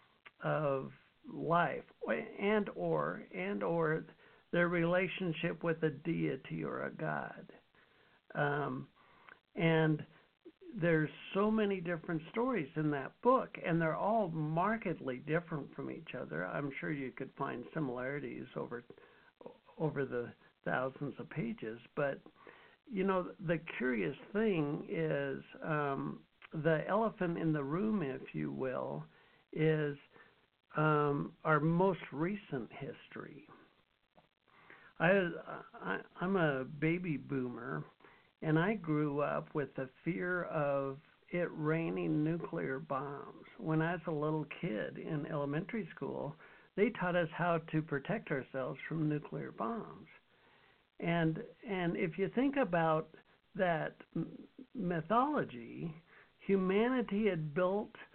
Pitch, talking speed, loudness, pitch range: 165 Hz, 120 wpm, -36 LUFS, 150-190 Hz